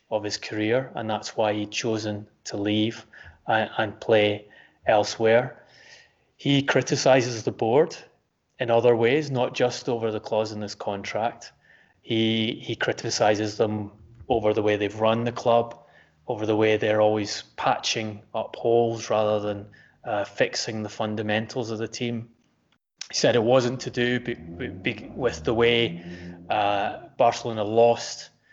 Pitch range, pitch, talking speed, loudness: 105-120 Hz, 110 Hz, 150 wpm, -25 LUFS